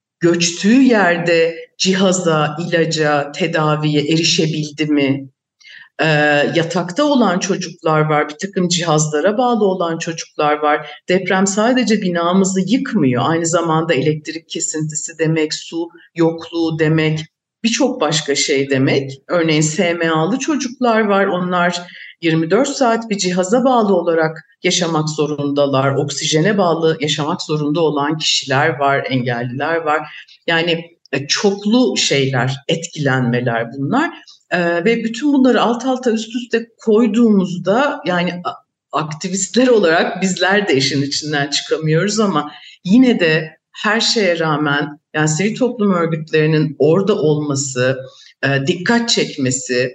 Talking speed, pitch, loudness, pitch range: 110 wpm, 165 Hz, -16 LUFS, 150-195 Hz